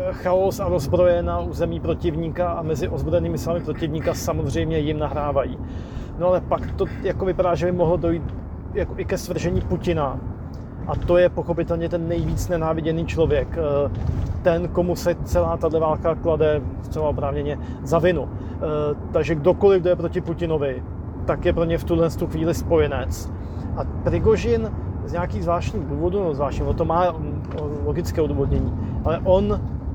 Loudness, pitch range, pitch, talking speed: -22 LUFS, 105-170 Hz, 160 Hz, 155 wpm